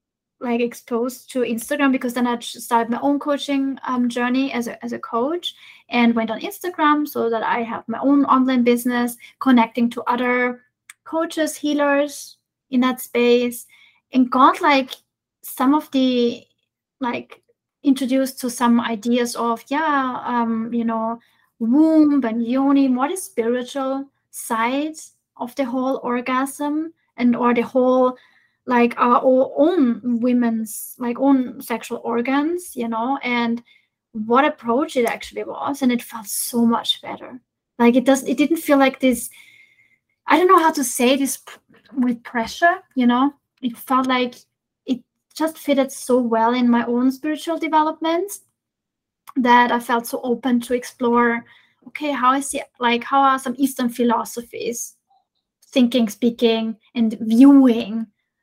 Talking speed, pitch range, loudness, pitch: 150 wpm, 235-280 Hz, -19 LUFS, 255 Hz